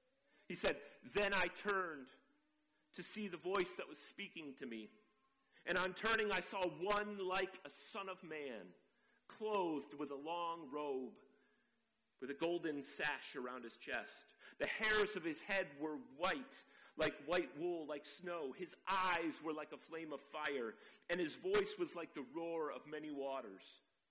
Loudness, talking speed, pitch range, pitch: -43 LUFS, 165 wpm, 150-205 Hz, 175 Hz